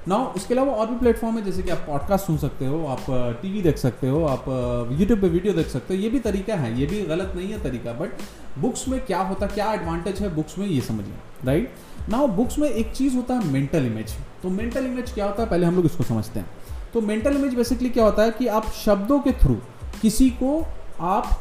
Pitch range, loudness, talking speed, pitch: 145-230 Hz, -23 LUFS, 240 wpm, 195 Hz